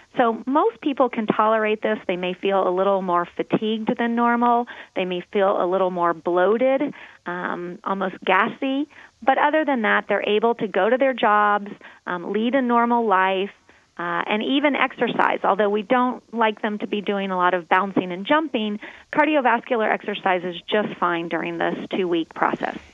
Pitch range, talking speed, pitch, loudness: 185-250 Hz, 180 wpm, 215 Hz, -21 LUFS